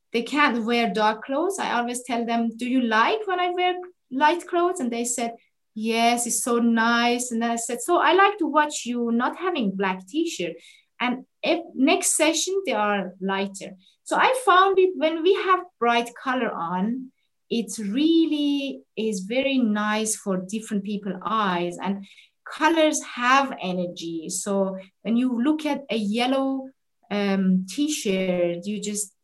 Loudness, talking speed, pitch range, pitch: -23 LUFS, 160 wpm, 210-295 Hz, 235 Hz